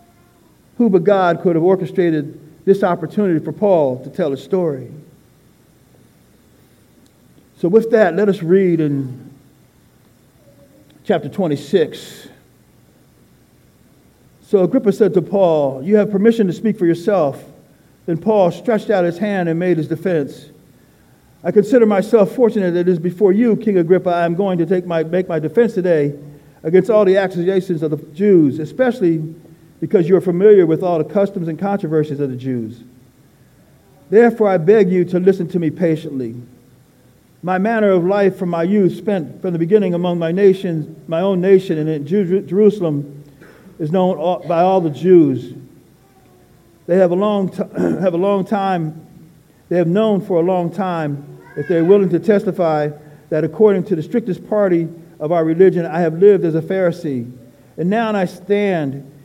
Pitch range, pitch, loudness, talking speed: 155-195 Hz, 175 Hz, -16 LUFS, 165 wpm